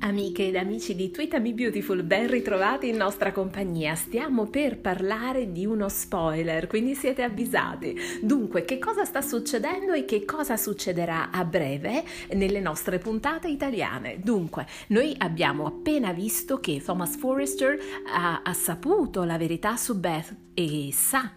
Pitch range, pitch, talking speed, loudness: 180-255 Hz, 200 Hz, 150 wpm, -27 LUFS